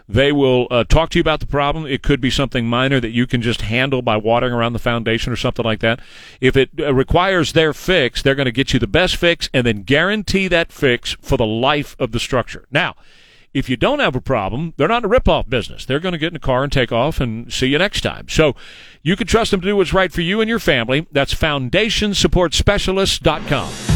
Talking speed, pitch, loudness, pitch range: 240 wpm, 135 Hz, -17 LUFS, 125-170 Hz